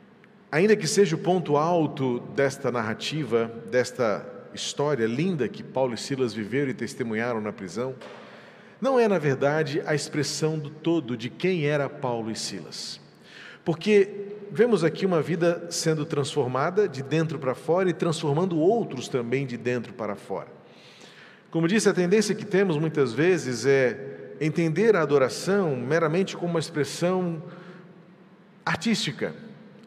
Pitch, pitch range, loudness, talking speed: 155 Hz, 135-185 Hz, -25 LUFS, 140 wpm